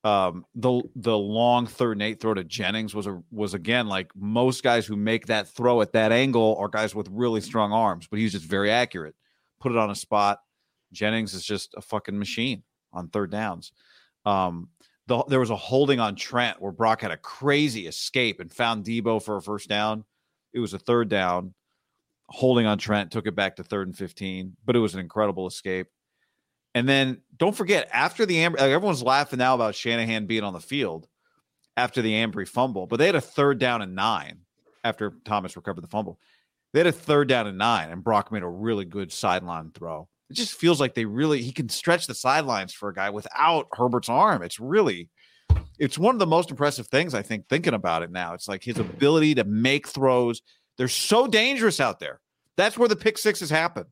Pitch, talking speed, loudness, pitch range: 115 Hz, 210 wpm, -24 LUFS, 100-130 Hz